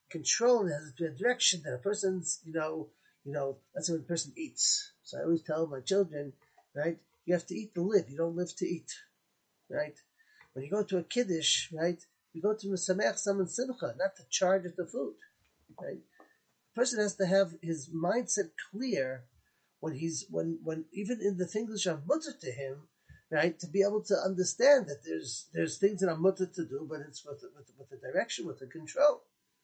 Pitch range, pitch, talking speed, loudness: 160-205 Hz, 180 Hz, 210 wpm, -32 LUFS